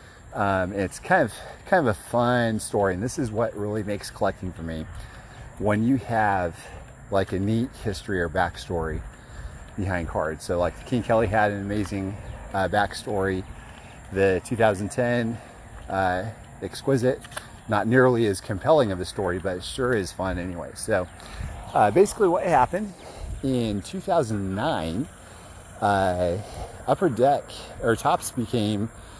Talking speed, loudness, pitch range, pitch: 140 wpm, -25 LUFS, 95-120 Hz, 105 Hz